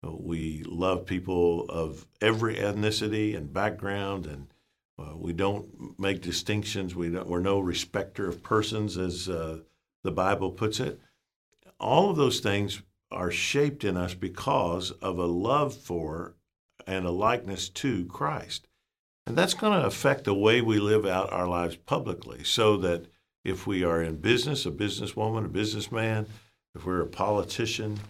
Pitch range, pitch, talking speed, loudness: 90-110 Hz, 95 Hz, 155 wpm, -28 LUFS